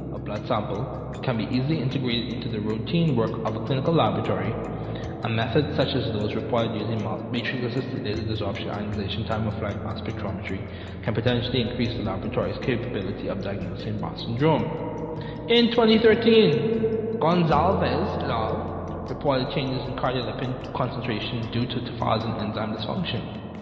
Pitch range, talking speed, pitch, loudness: 110-135 Hz, 130 wpm, 115 Hz, -25 LUFS